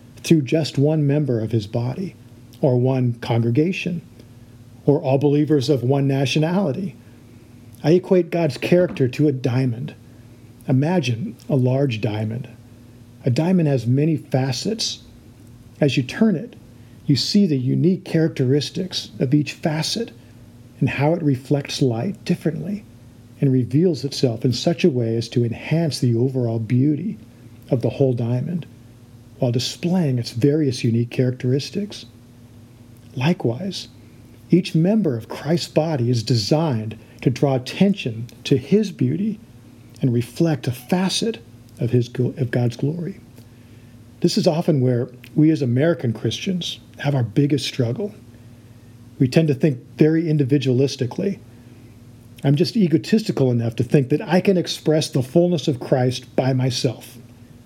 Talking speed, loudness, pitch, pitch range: 135 wpm, -20 LUFS, 130 Hz, 120-155 Hz